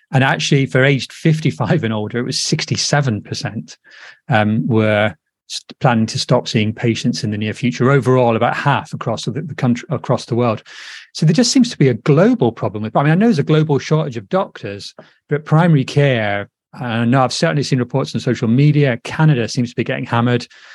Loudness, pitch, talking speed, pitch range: -16 LUFS, 130 Hz, 205 wpm, 115-145 Hz